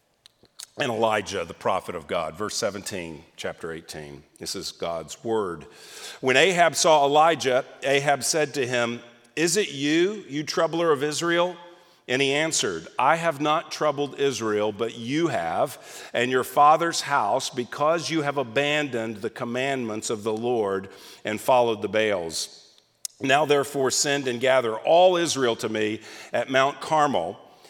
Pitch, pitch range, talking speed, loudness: 140 Hz, 115-155 Hz, 150 wpm, -24 LUFS